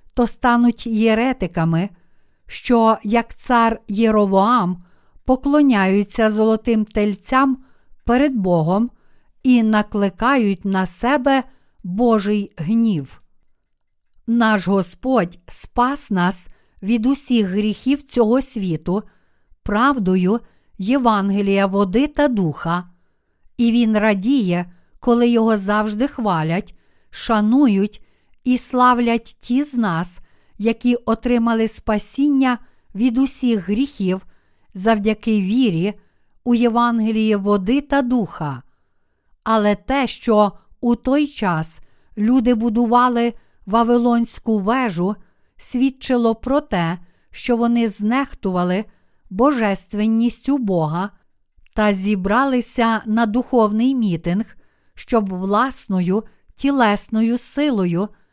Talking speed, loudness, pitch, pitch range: 85 wpm, -18 LUFS, 225 Hz, 195-245 Hz